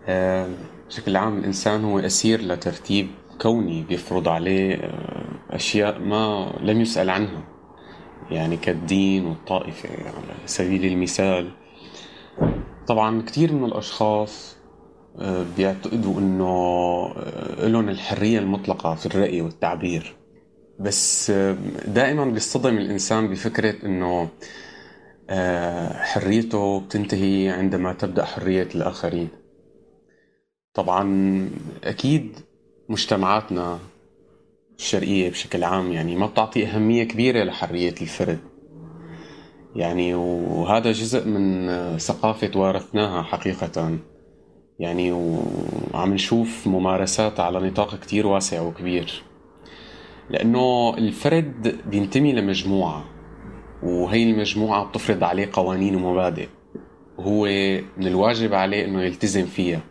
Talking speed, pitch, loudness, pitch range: 90 wpm, 95 Hz, -22 LUFS, 90-110 Hz